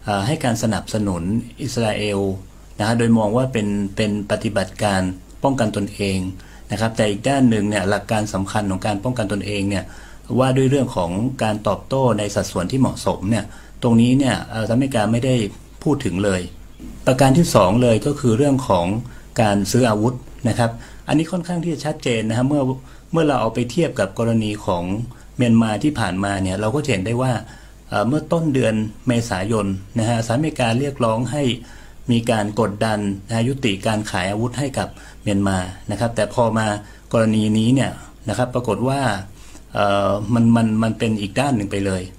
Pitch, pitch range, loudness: 110 Hz, 100-125 Hz, -20 LUFS